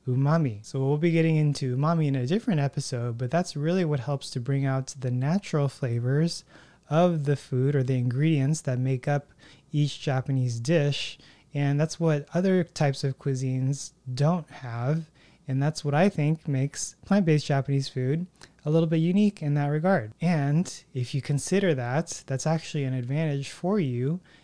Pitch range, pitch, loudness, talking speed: 135-165 Hz, 145 Hz, -27 LUFS, 175 wpm